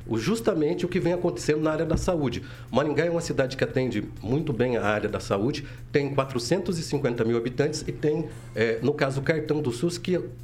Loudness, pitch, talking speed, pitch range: -26 LUFS, 145 Hz, 200 wpm, 120-160 Hz